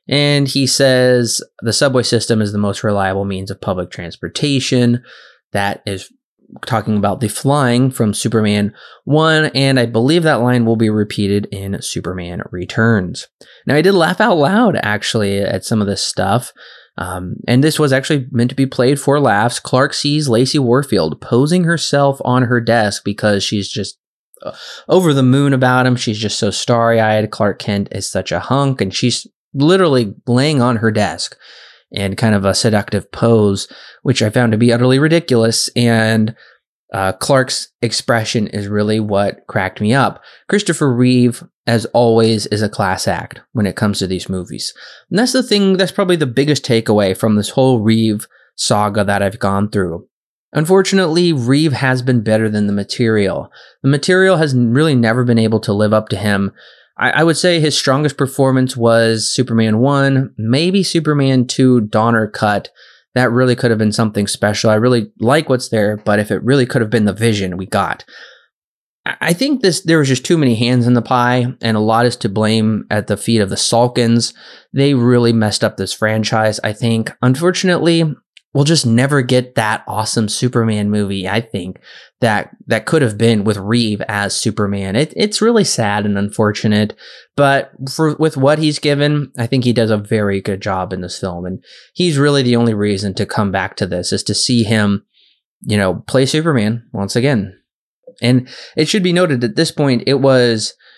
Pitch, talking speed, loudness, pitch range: 115 Hz, 185 wpm, -14 LUFS, 105-135 Hz